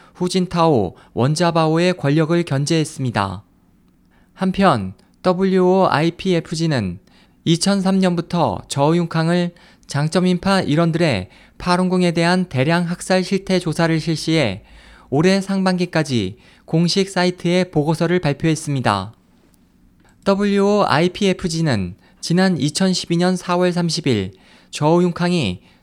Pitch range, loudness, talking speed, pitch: 145-180 Hz, -18 LUFS, 235 characters per minute, 170 Hz